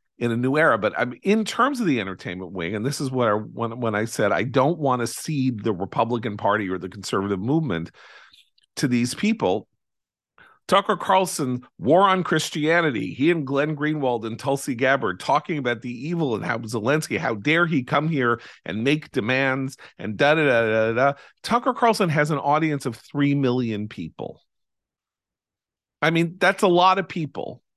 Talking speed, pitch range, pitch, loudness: 180 wpm, 115-160 Hz, 140 Hz, -22 LUFS